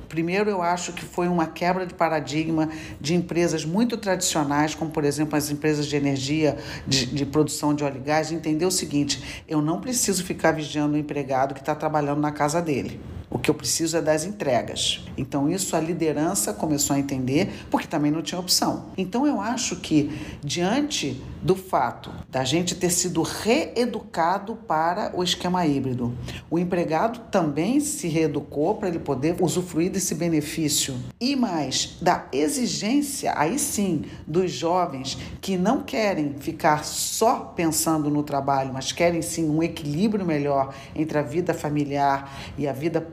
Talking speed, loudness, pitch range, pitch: 165 wpm, -24 LUFS, 145-180 Hz, 160 Hz